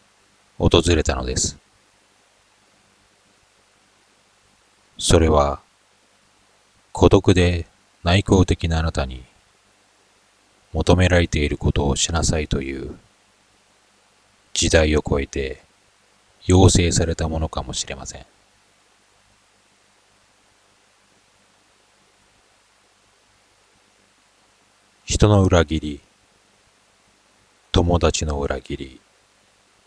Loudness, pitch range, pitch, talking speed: -19 LUFS, 80-105 Hz, 95 Hz, 135 characters per minute